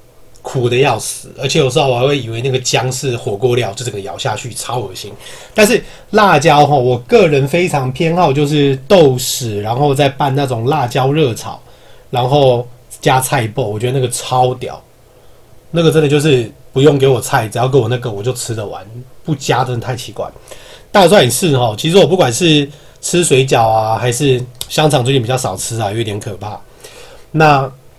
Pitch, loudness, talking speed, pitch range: 130 Hz, -13 LUFS, 275 characters per minute, 125-145 Hz